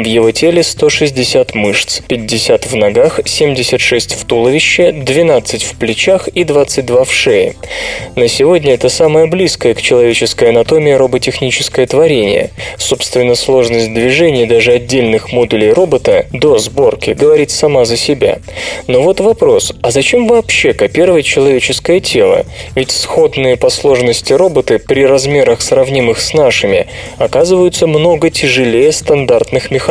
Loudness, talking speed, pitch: -10 LUFS, 130 wpm, 190 Hz